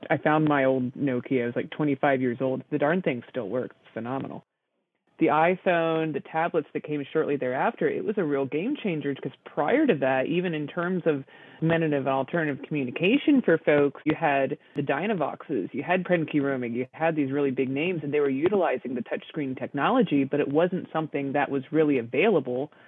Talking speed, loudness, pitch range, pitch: 190 wpm, -26 LUFS, 135-160 Hz, 145 Hz